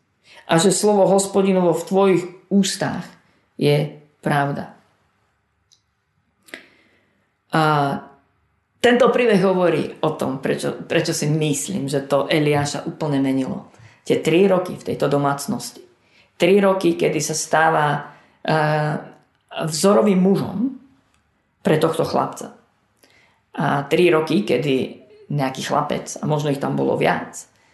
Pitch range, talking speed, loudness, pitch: 140-185 Hz, 115 wpm, -19 LUFS, 155 Hz